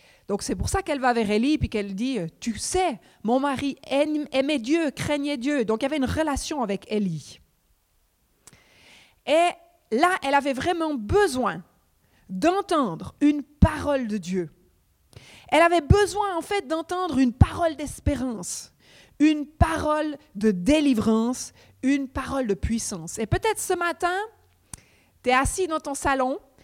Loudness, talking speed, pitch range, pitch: -24 LUFS, 145 wpm, 230-320 Hz, 280 Hz